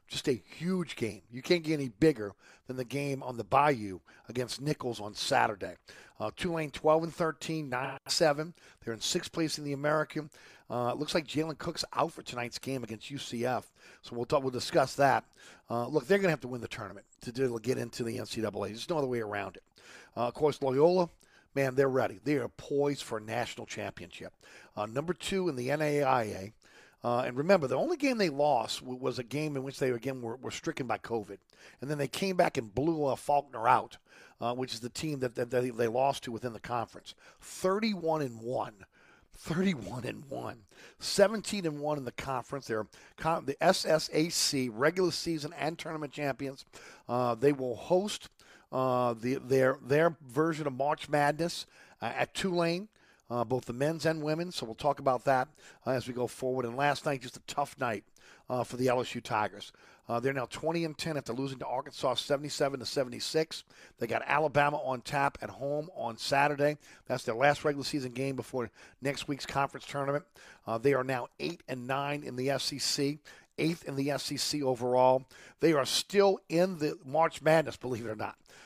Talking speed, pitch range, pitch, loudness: 195 wpm, 125-155 Hz, 140 Hz, -32 LUFS